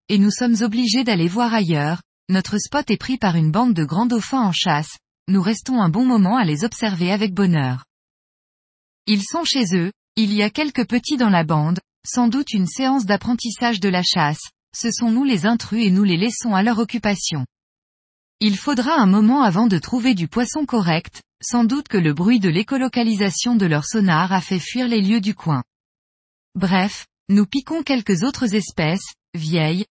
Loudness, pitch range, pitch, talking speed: -19 LUFS, 180-240 Hz, 210 Hz, 190 wpm